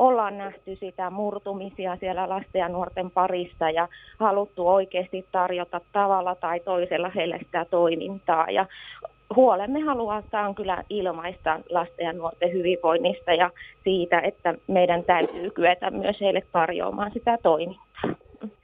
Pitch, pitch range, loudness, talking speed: 185 Hz, 175-200 Hz, -25 LUFS, 130 wpm